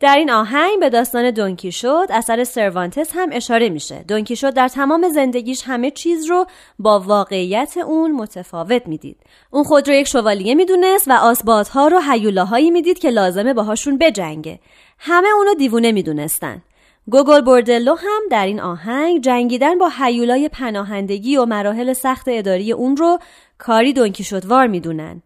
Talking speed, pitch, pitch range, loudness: 155 wpm, 250 Hz, 210-295 Hz, -15 LUFS